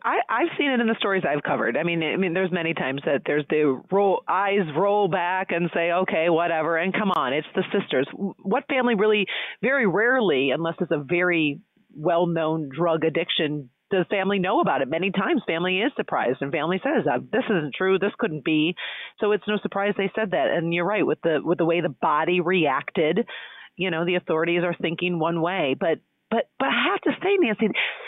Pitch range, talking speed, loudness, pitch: 165-200 Hz, 210 wpm, -23 LUFS, 180 Hz